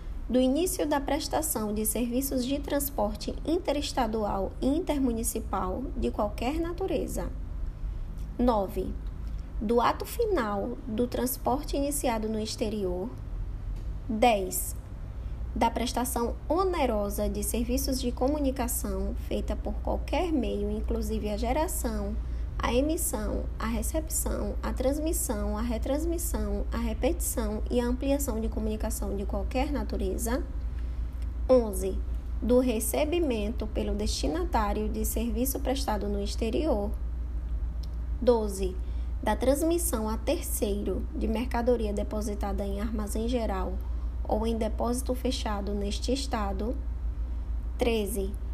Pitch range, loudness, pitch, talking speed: 200-260 Hz, -30 LUFS, 225 Hz, 105 wpm